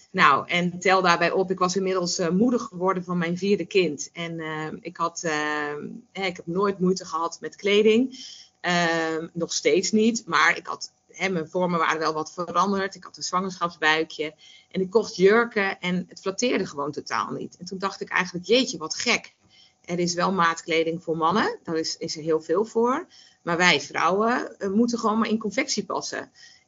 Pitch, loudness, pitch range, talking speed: 180 Hz, -24 LUFS, 165-200 Hz, 195 wpm